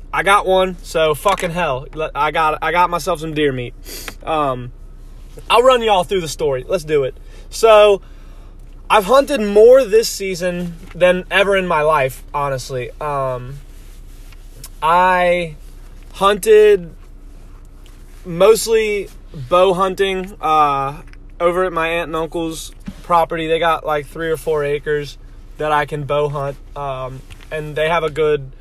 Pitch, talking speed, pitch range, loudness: 165 Hz, 145 wpm, 145-190 Hz, -16 LUFS